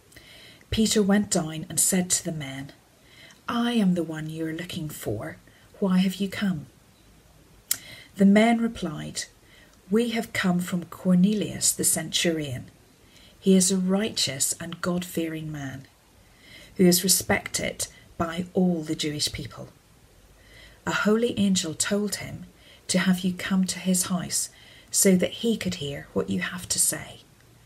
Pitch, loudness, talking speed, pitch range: 175 Hz, -25 LUFS, 150 wpm, 145-190 Hz